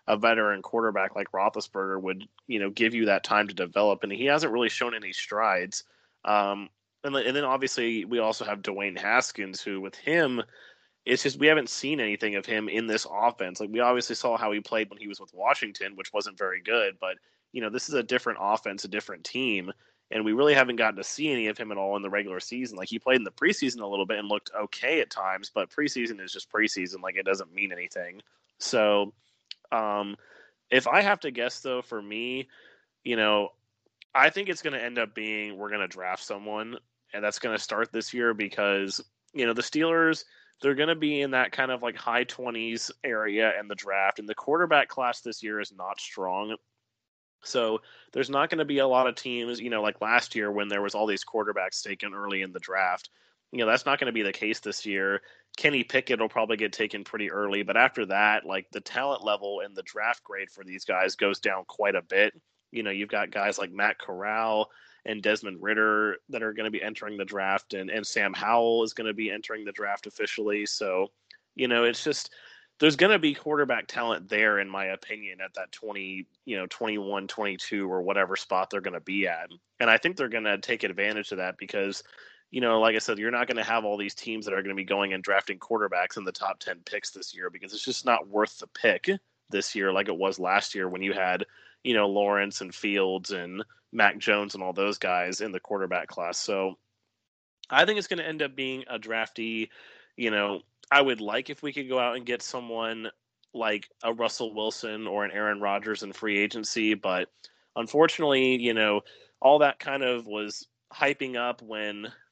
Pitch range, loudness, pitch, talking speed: 100-120 Hz, -27 LUFS, 110 Hz, 220 wpm